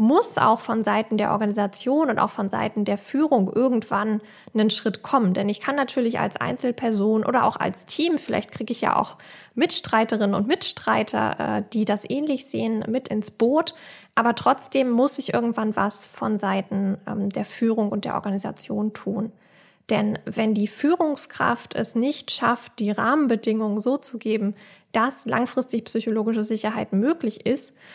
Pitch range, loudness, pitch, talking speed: 210-255 Hz, -23 LUFS, 220 Hz, 155 wpm